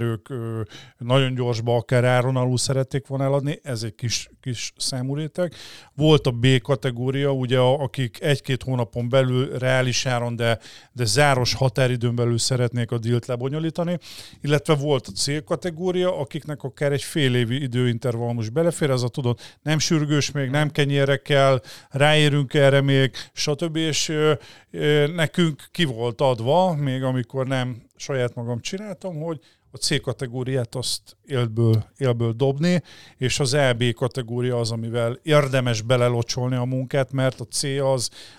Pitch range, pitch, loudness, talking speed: 120-145 Hz, 130 Hz, -22 LUFS, 150 wpm